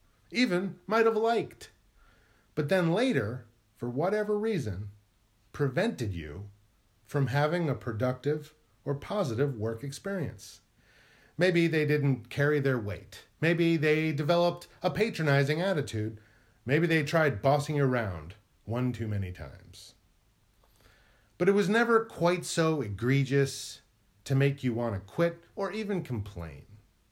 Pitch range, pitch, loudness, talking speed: 110-165 Hz, 140 Hz, -29 LUFS, 130 wpm